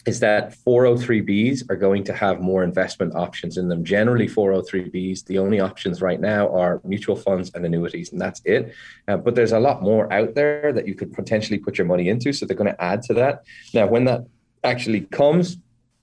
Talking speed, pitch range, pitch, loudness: 205 wpm, 95-120 Hz, 105 Hz, -21 LUFS